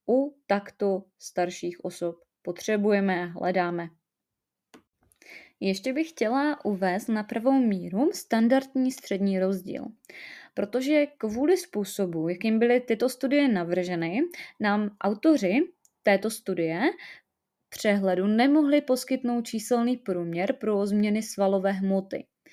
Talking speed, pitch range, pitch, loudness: 100 wpm, 190-260 Hz, 215 Hz, -26 LUFS